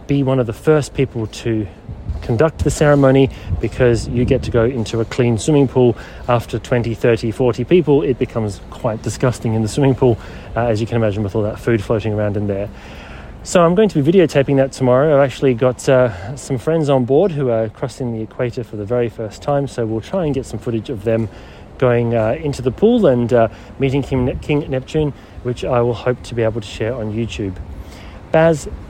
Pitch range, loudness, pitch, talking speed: 110-135 Hz, -17 LUFS, 120 Hz, 220 wpm